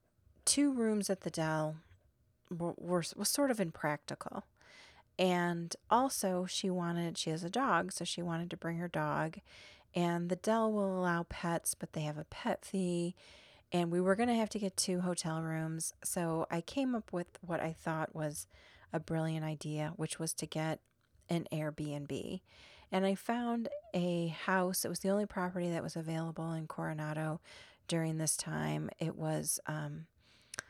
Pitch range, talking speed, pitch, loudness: 160-190 Hz, 170 wpm, 170 Hz, -36 LUFS